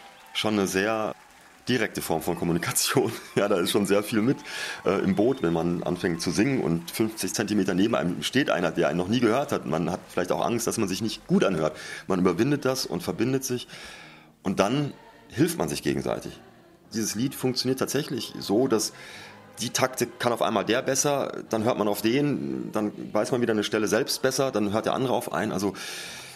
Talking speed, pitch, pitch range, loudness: 205 wpm, 110 Hz, 100-130 Hz, -26 LUFS